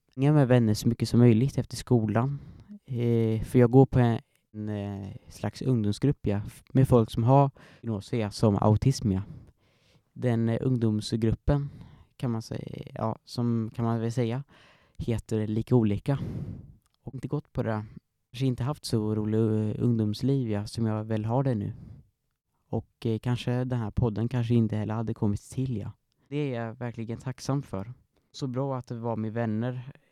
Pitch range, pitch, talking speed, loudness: 110-130 Hz, 120 Hz, 175 wpm, -28 LUFS